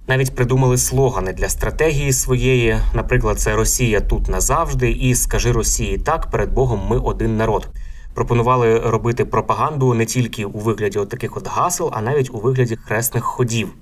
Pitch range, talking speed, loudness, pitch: 110-125 Hz, 160 wpm, -18 LUFS, 115 Hz